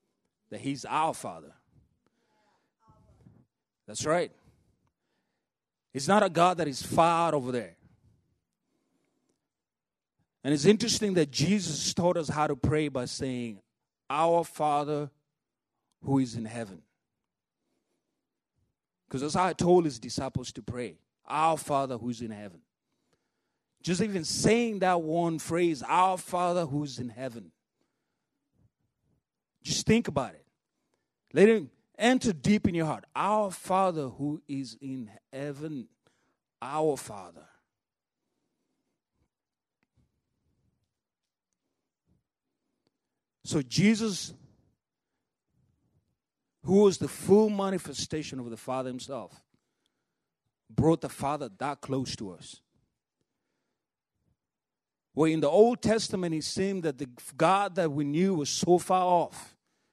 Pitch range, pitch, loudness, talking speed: 135-180 Hz, 155 Hz, -28 LUFS, 115 wpm